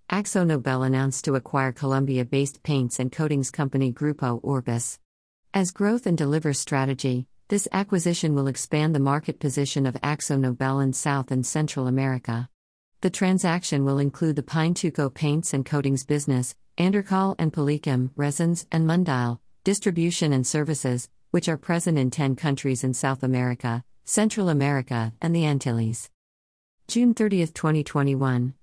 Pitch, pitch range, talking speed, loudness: 140 Hz, 130-165 Hz, 145 wpm, -25 LUFS